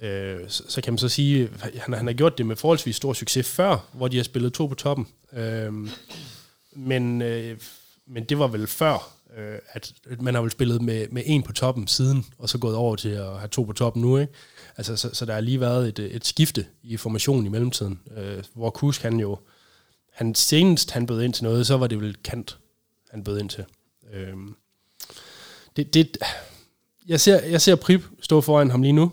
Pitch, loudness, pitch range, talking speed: 120 Hz, -23 LUFS, 110-135 Hz, 200 wpm